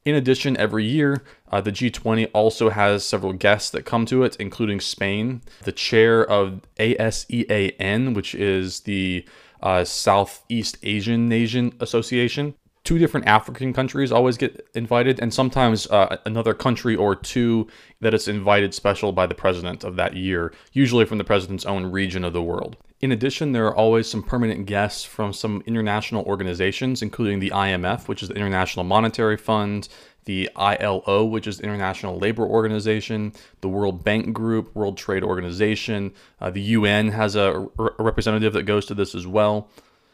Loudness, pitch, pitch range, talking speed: -22 LUFS, 105 Hz, 100-115 Hz, 165 wpm